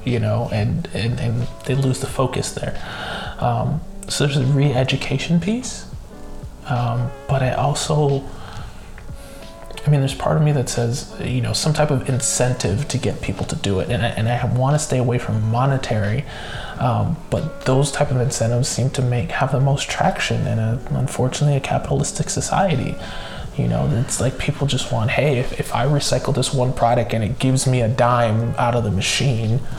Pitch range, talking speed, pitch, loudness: 120-140 Hz, 190 wpm, 125 Hz, -20 LUFS